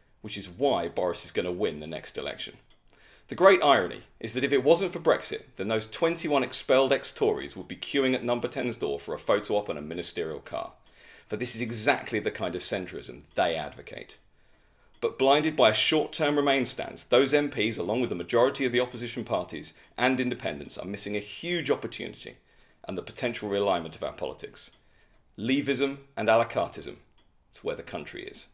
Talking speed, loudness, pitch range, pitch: 195 wpm, -28 LUFS, 110-140 Hz, 130 Hz